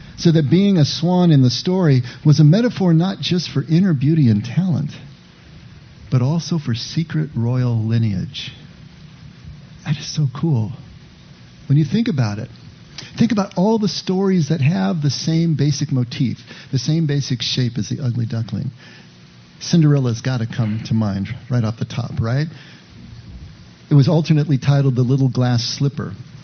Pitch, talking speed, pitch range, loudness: 145 Hz, 160 wpm, 125-160 Hz, -18 LUFS